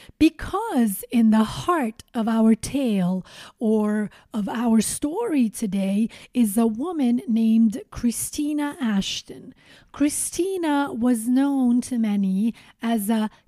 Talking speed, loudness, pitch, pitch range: 110 wpm, -23 LUFS, 230 Hz, 220-275 Hz